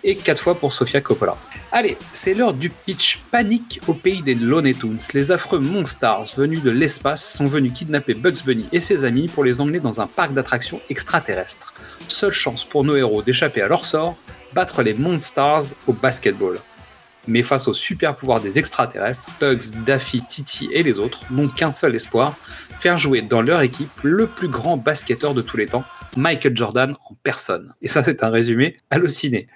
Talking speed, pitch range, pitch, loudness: 190 wpm, 125-160 Hz, 140 Hz, -19 LUFS